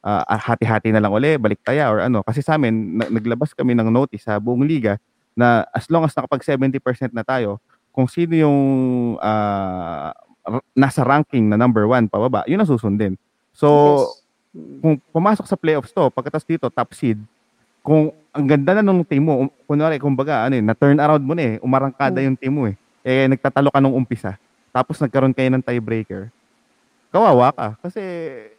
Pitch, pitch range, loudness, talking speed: 130 Hz, 115-150 Hz, -18 LUFS, 175 wpm